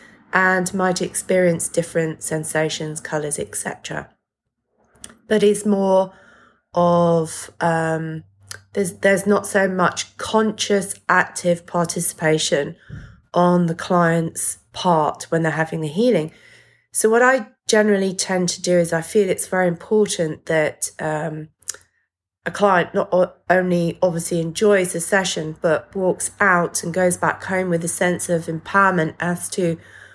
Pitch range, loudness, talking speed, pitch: 165-195 Hz, -19 LUFS, 135 wpm, 175 Hz